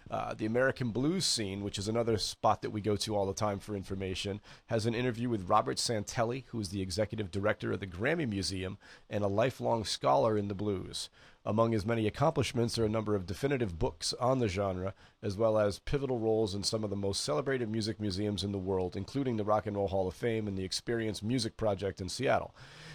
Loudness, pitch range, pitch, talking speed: -33 LUFS, 100-115 Hz, 105 Hz, 220 wpm